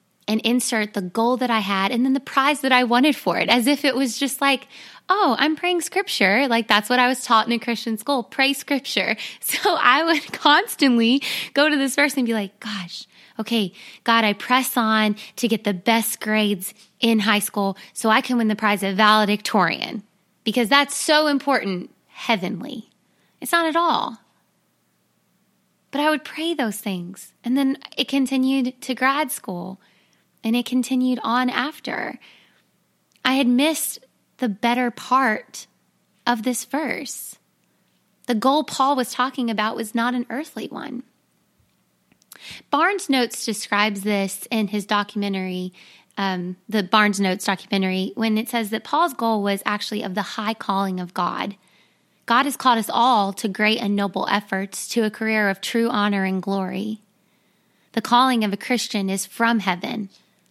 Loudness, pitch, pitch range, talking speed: -21 LUFS, 230 Hz, 205-265 Hz, 170 wpm